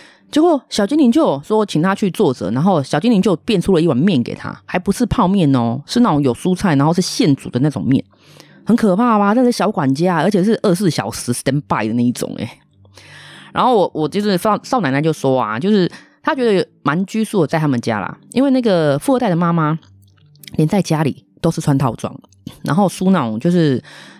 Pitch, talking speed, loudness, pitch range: 175 Hz, 320 characters per minute, -16 LUFS, 140-210 Hz